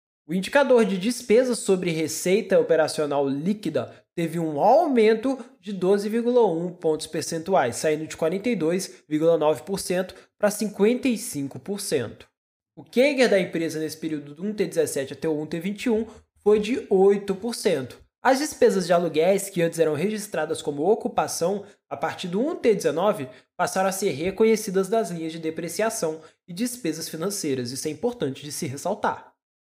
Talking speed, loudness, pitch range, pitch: 130 wpm, -24 LUFS, 160-220 Hz, 185 Hz